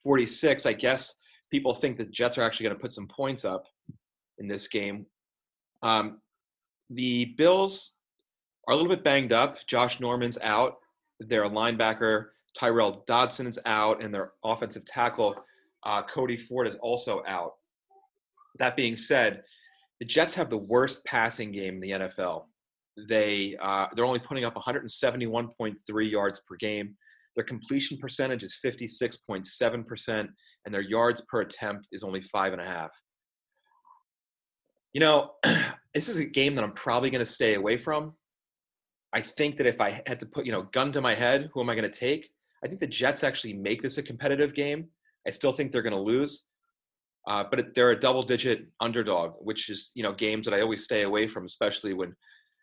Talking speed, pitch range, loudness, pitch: 180 wpm, 110-140 Hz, -28 LUFS, 120 Hz